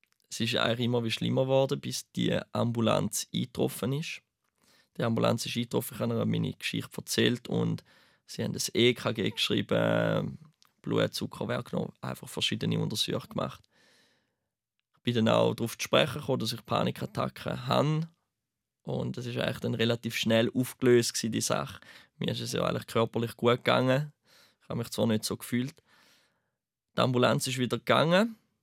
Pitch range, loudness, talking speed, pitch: 115-130 Hz, -29 LUFS, 155 wpm, 120 Hz